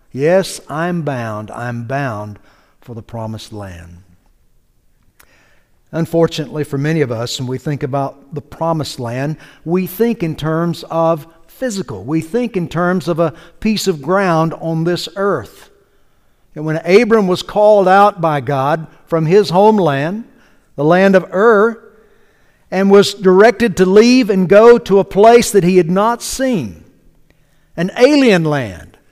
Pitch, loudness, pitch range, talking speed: 165 Hz, -13 LUFS, 140-200 Hz, 150 wpm